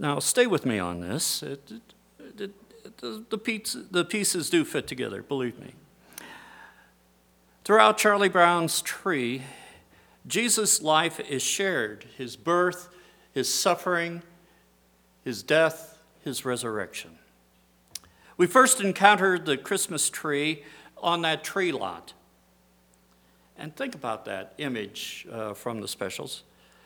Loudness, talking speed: -25 LUFS, 115 wpm